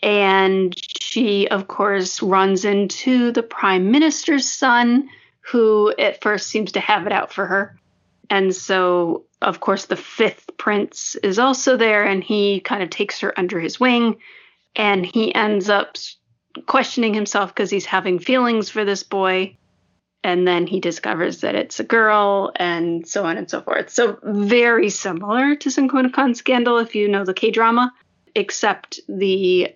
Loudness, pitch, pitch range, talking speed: -18 LUFS, 205 Hz, 190-235 Hz, 160 wpm